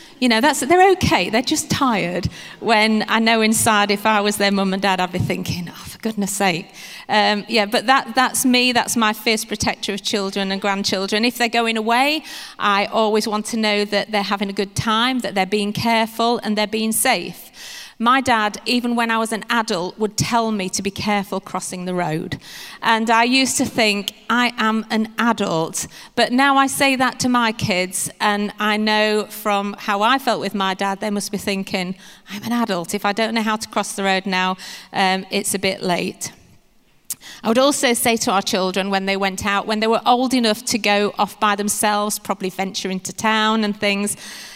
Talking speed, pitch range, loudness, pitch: 210 wpm, 200-230 Hz, -18 LUFS, 210 Hz